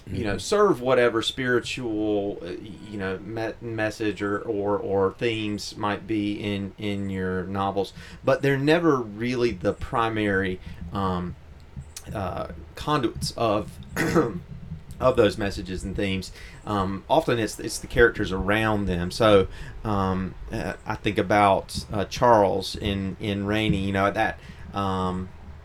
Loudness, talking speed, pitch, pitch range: -25 LUFS, 130 wpm, 100 Hz, 95-110 Hz